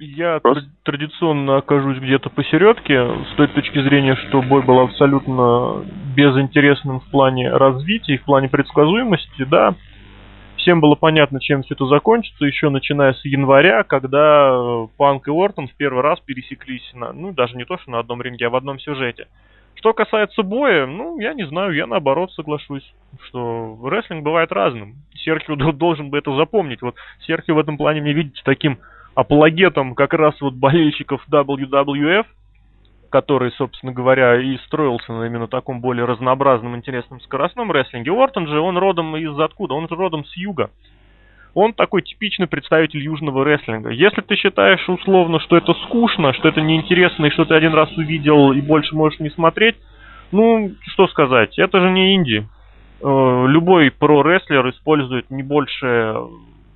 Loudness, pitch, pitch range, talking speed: -16 LUFS, 145 Hz, 130-165 Hz, 160 wpm